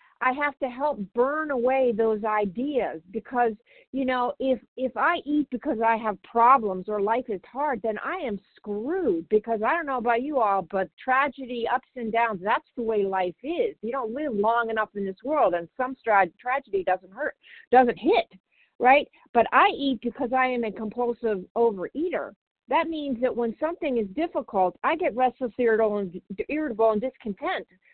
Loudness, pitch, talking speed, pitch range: -25 LUFS, 240 Hz, 180 wpm, 215-270 Hz